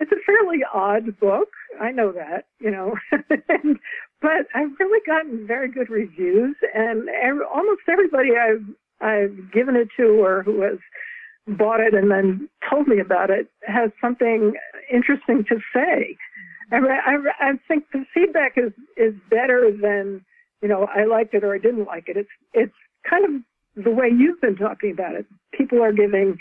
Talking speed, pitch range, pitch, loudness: 175 wpm, 210-290 Hz, 235 Hz, -20 LUFS